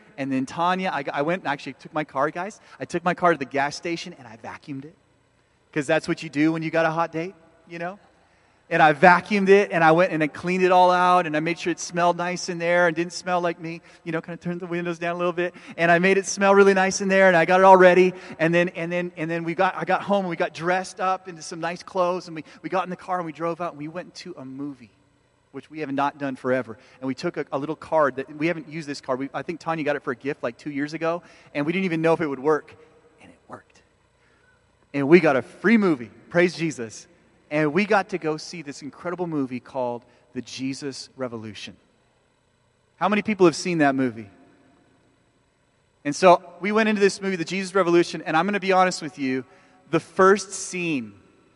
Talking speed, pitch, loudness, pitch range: 255 wpm, 170 Hz, -22 LUFS, 145-180 Hz